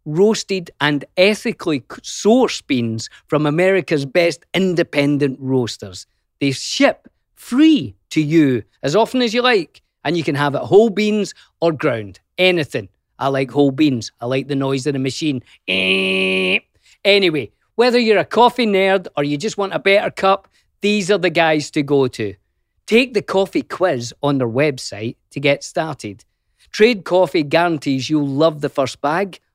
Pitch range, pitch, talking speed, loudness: 135-195 Hz, 155 Hz, 160 wpm, -17 LUFS